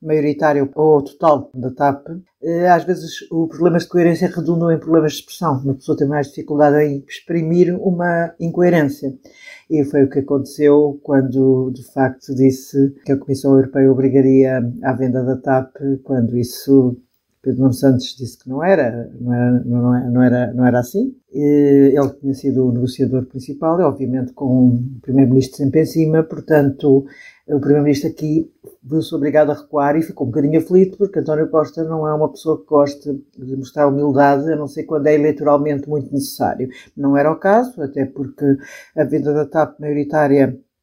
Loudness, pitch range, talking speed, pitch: -16 LUFS, 135-155 Hz, 170 wpm, 145 Hz